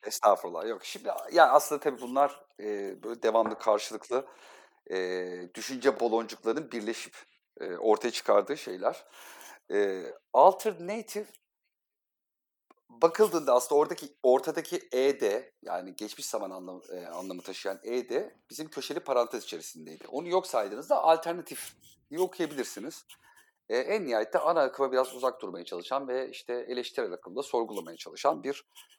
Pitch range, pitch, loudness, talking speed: 110-160 Hz, 130 Hz, -30 LUFS, 125 wpm